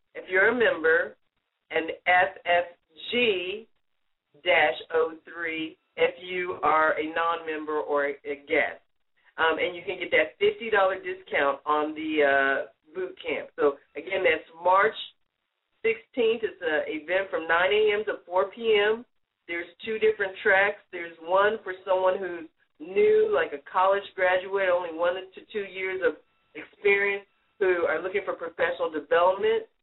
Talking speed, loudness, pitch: 145 wpm, -26 LUFS, 195 Hz